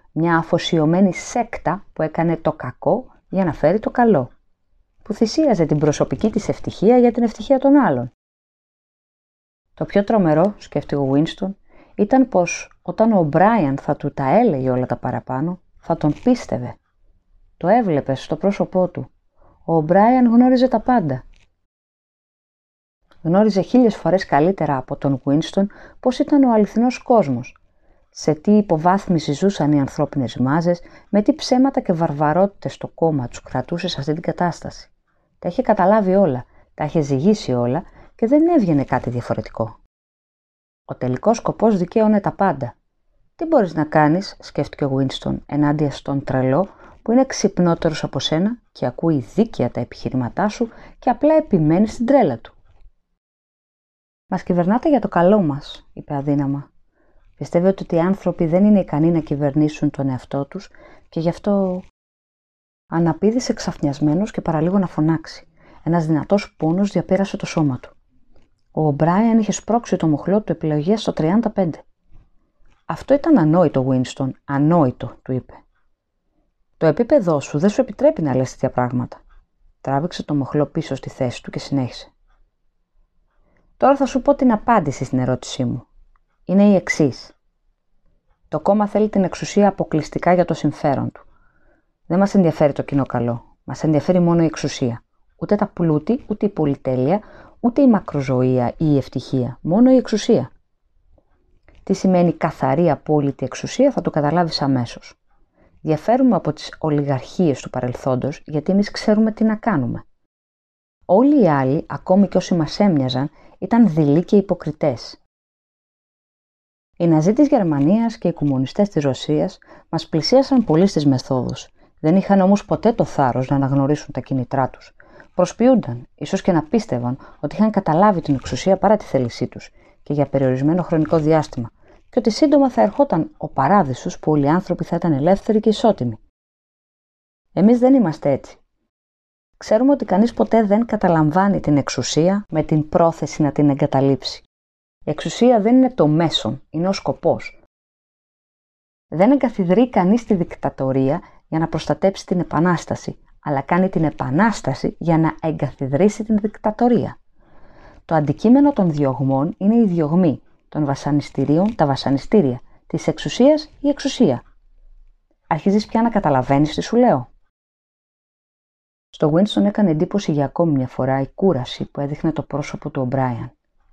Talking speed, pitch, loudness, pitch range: 150 wpm, 160 Hz, -18 LUFS, 140-200 Hz